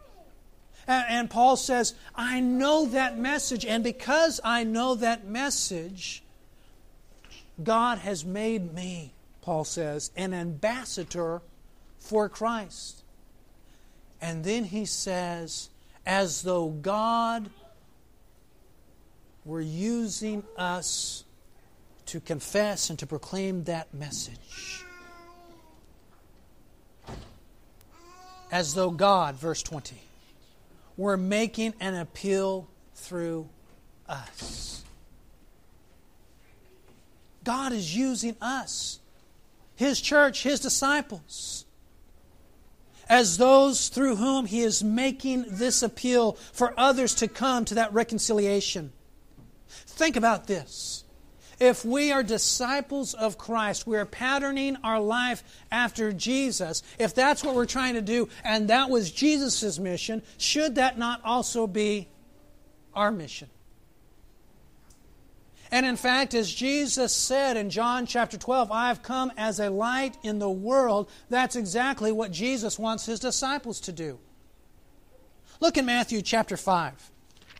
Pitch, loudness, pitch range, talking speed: 225 Hz, -27 LUFS, 185-255 Hz, 110 wpm